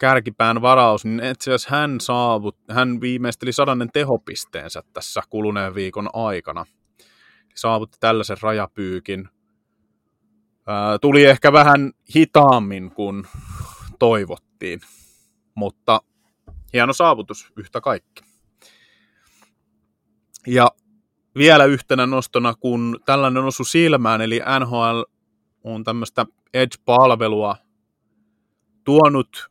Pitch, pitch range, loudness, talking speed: 115 Hz, 105-130 Hz, -17 LUFS, 85 wpm